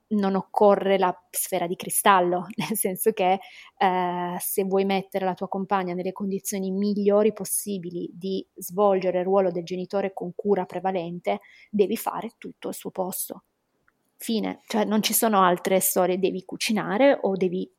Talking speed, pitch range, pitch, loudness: 155 wpm, 185-205 Hz, 195 Hz, -24 LUFS